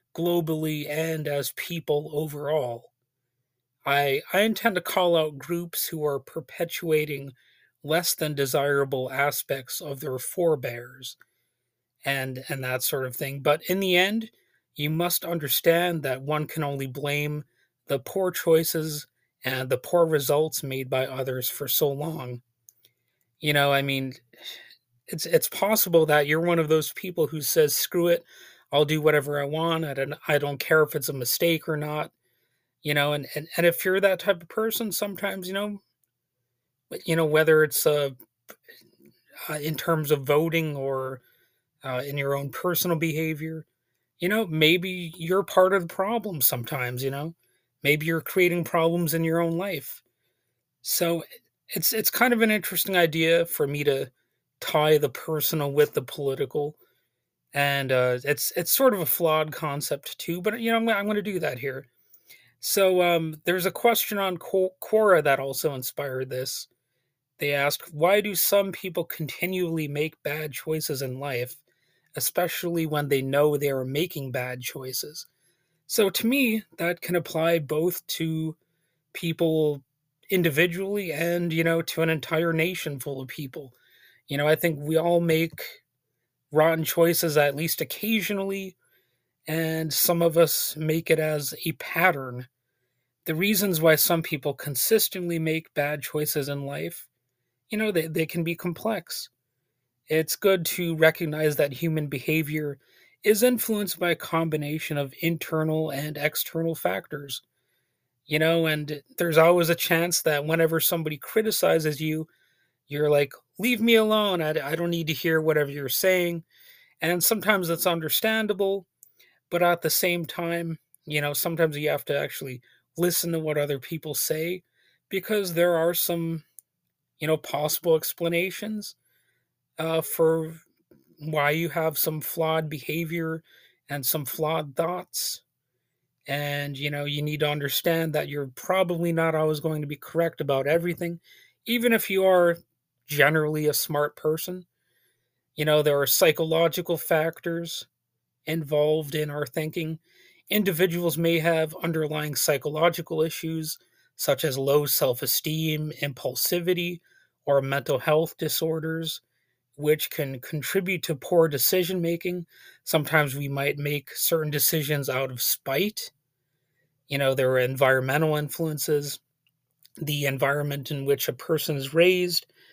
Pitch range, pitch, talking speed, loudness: 145-170 Hz, 155 Hz, 150 wpm, -25 LUFS